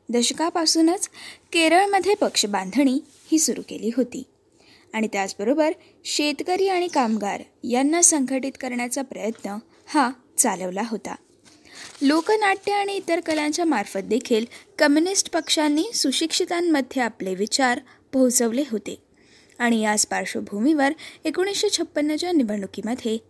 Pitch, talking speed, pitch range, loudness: 285 Hz, 100 wpm, 235-335 Hz, -22 LUFS